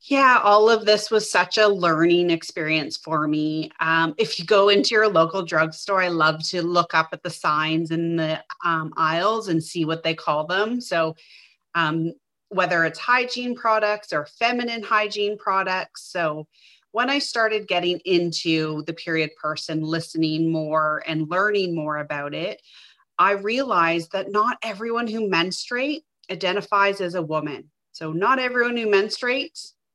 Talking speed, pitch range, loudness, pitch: 160 wpm, 160-215 Hz, -22 LUFS, 180 Hz